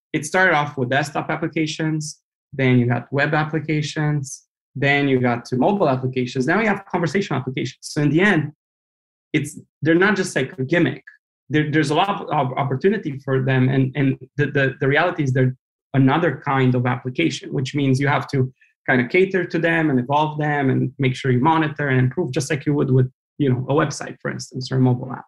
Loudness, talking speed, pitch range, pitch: -20 LUFS, 210 wpm, 130-155 Hz, 140 Hz